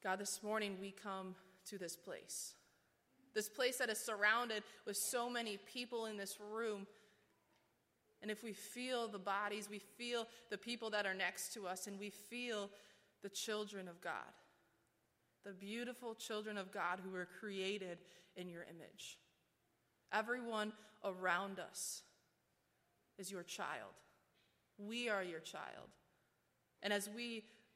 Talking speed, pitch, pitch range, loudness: 145 wpm, 205 Hz, 190-220 Hz, -44 LUFS